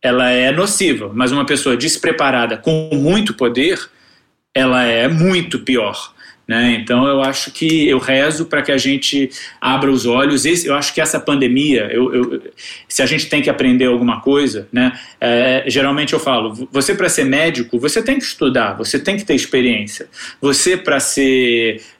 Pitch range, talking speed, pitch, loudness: 125-150 Hz, 175 wpm, 135 Hz, -15 LUFS